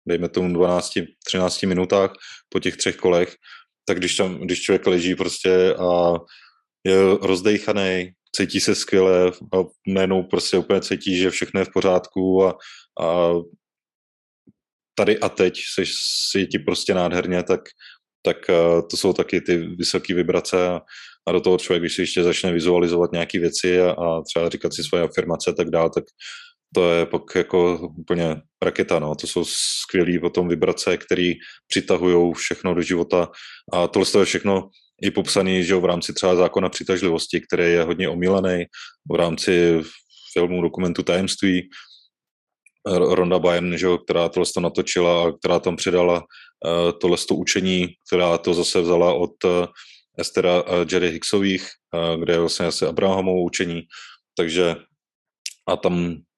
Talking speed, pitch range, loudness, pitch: 155 wpm, 85-95 Hz, -20 LUFS, 90 Hz